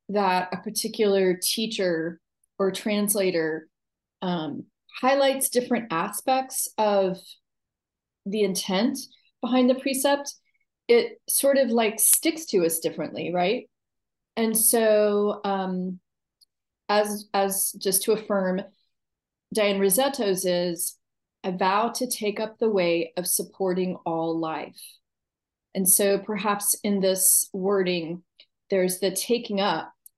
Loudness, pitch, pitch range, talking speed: -24 LUFS, 200 Hz, 185-225 Hz, 115 wpm